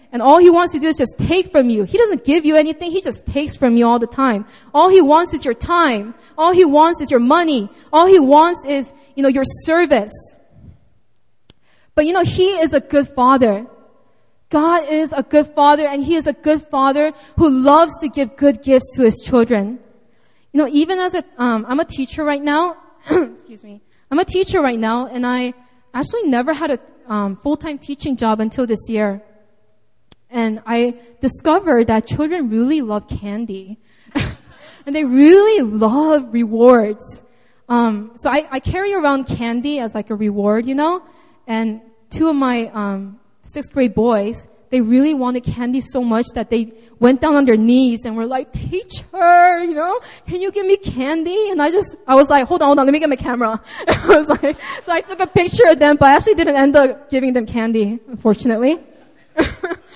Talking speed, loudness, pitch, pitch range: 195 wpm, -15 LUFS, 275 Hz, 235-315 Hz